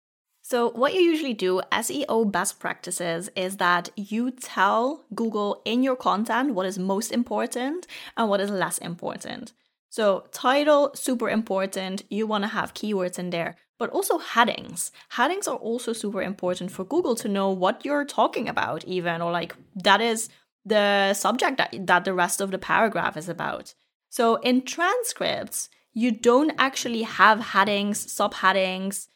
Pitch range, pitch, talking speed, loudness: 190-245 Hz, 210 Hz, 160 wpm, -24 LUFS